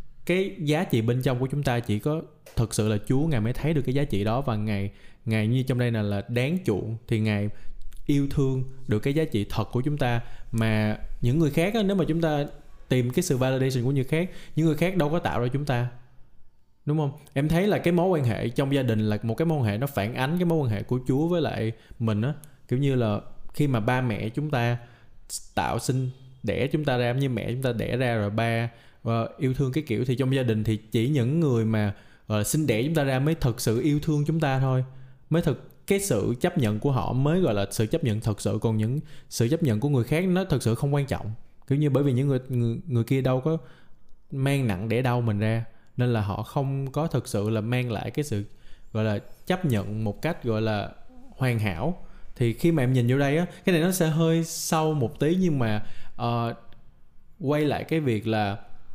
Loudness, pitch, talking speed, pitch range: -26 LUFS, 125 Hz, 245 wpm, 110-150 Hz